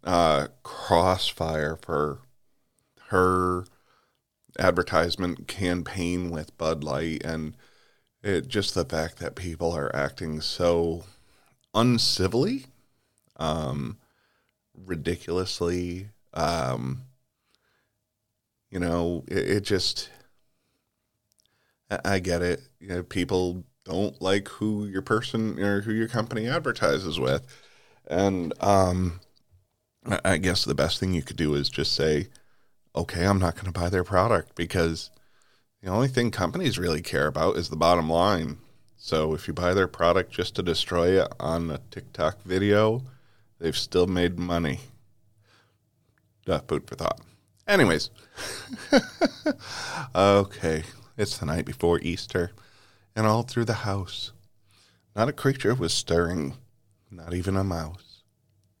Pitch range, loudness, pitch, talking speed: 85-105 Hz, -26 LUFS, 95 Hz, 125 wpm